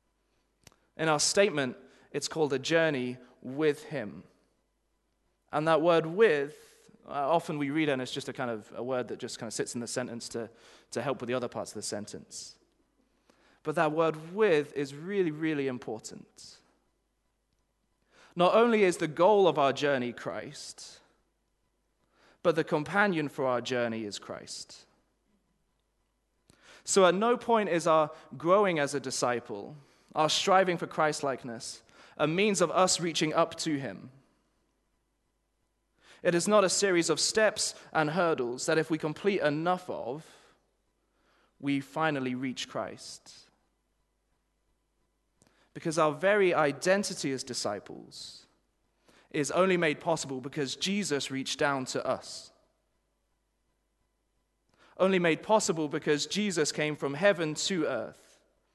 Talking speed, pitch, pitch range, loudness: 135 wpm, 155 Hz, 140-180 Hz, -29 LUFS